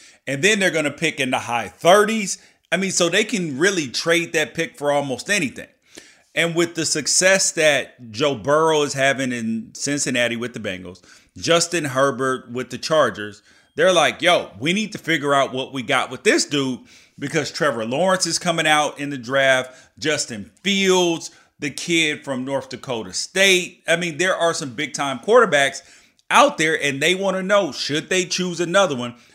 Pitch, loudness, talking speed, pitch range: 150 Hz, -19 LUFS, 190 wpm, 130-175 Hz